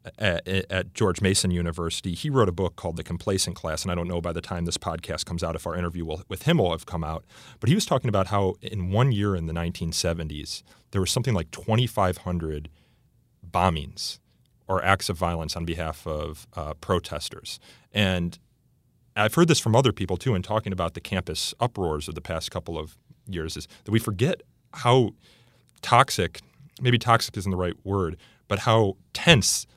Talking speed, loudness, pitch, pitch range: 195 wpm, -25 LUFS, 95 Hz, 85-110 Hz